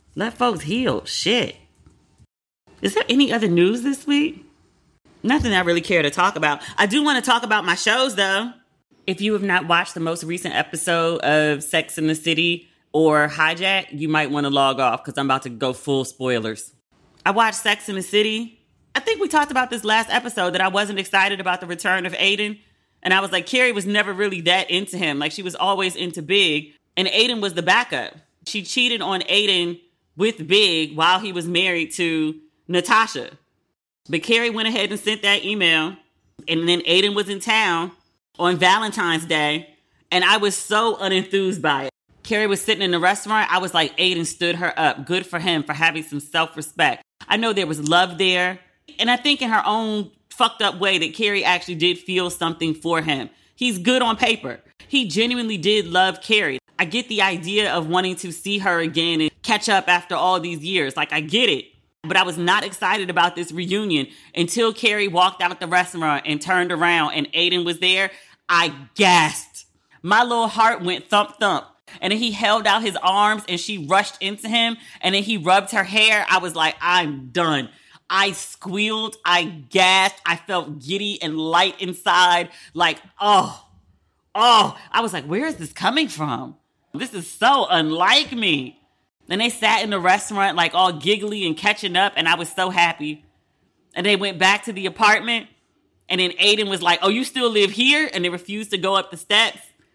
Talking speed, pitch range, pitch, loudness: 200 wpm, 170-210 Hz, 185 Hz, -19 LUFS